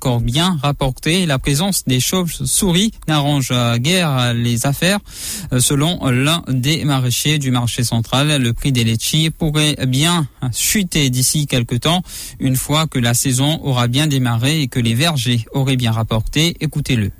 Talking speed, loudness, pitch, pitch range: 155 wpm, -16 LUFS, 135 Hz, 125-155 Hz